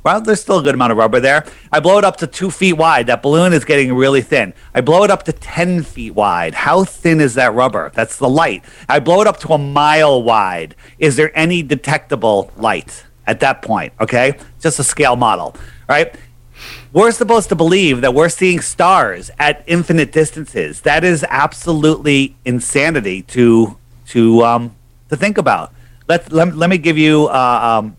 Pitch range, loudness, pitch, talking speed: 120-170 Hz, -13 LUFS, 150 Hz, 195 wpm